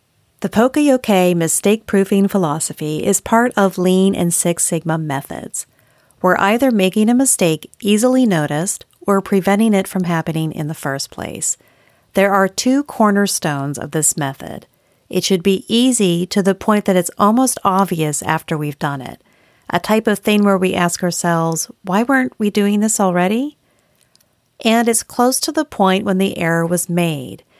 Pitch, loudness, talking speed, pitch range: 195 Hz, -16 LUFS, 165 wpm, 170-215 Hz